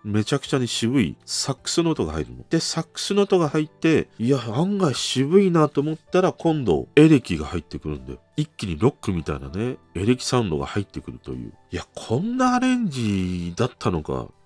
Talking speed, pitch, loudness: 400 characters per minute, 125 Hz, -22 LUFS